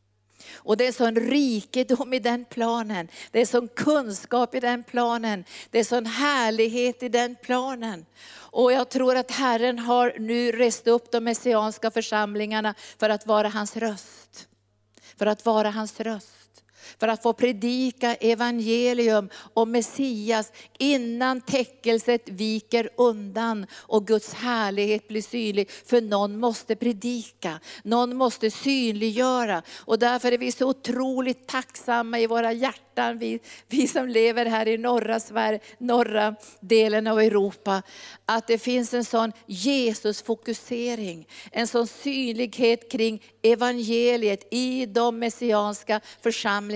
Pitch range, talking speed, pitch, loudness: 215-245 Hz, 135 wpm, 230 Hz, -24 LUFS